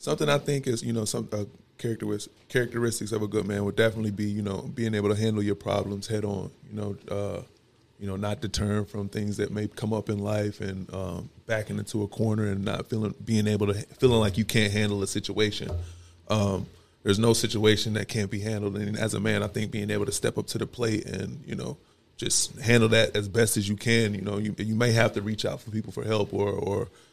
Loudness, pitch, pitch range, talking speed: -27 LUFS, 105 Hz, 100-110 Hz, 240 wpm